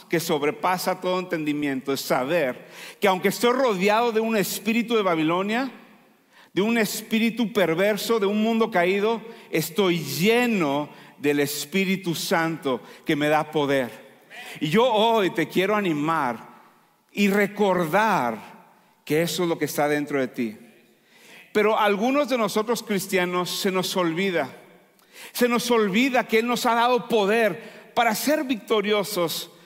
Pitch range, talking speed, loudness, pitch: 165-225 Hz, 140 wpm, -23 LUFS, 195 Hz